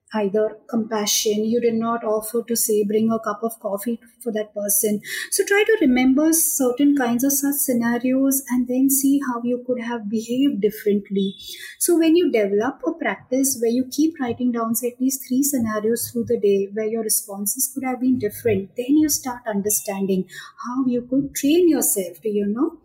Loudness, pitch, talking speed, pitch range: -21 LUFS, 235 Hz, 190 wpm, 215-270 Hz